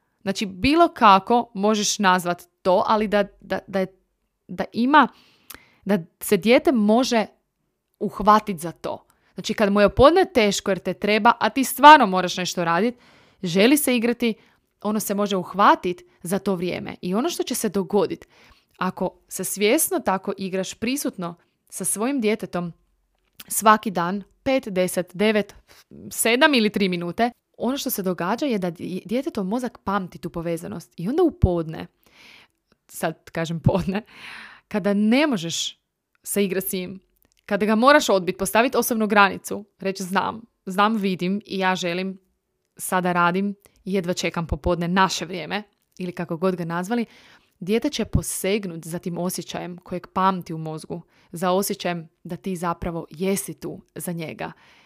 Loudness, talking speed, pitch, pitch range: -22 LUFS, 155 wpm, 195 Hz, 180-220 Hz